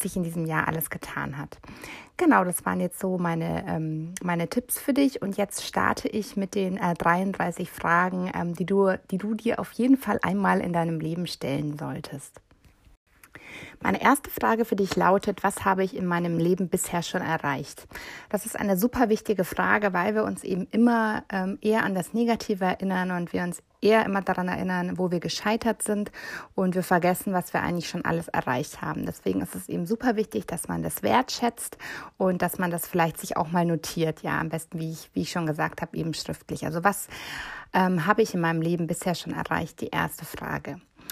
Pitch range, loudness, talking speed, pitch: 170-205 Hz, -26 LUFS, 195 wpm, 185 Hz